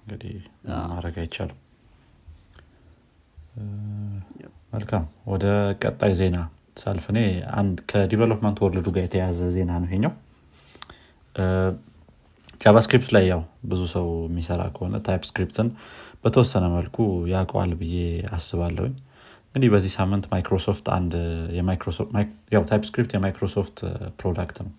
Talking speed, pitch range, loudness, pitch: 95 wpm, 85-105 Hz, -24 LUFS, 95 Hz